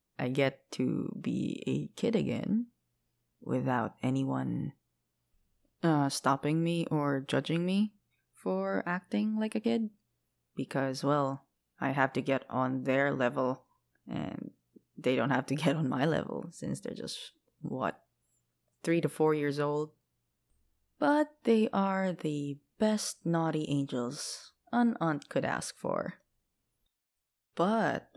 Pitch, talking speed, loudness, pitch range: 140 Hz, 130 wpm, -32 LUFS, 130-175 Hz